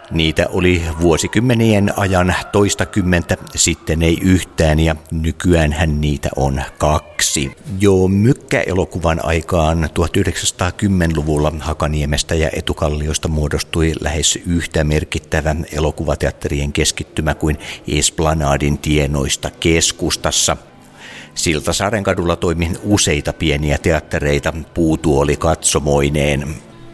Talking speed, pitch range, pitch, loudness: 85 wpm, 75-90 Hz, 80 Hz, -16 LUFS